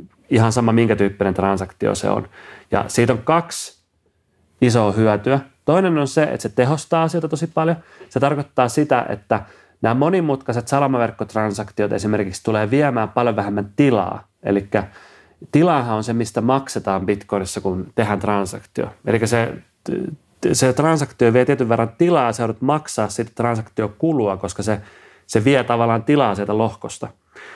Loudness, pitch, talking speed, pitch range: -19 LUFS, 115 Hz, 145 wpm, 105-140 Hz